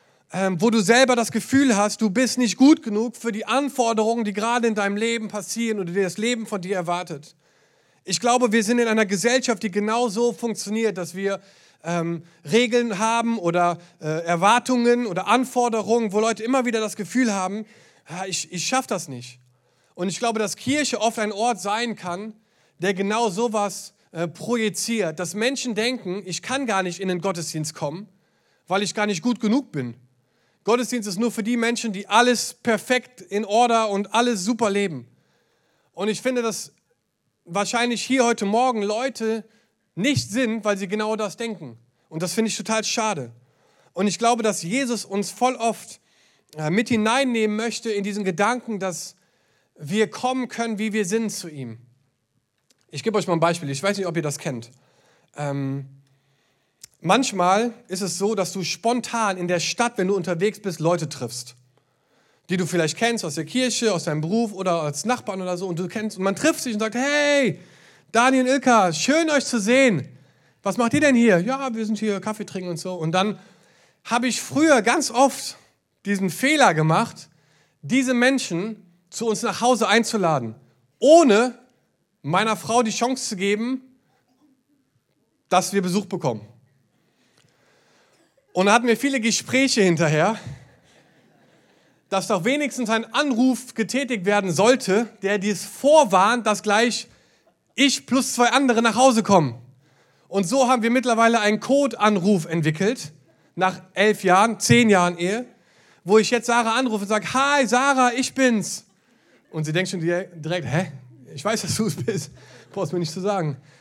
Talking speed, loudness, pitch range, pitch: 170 wpm, -21 LUFS, 180-235 Hz, 210 Hz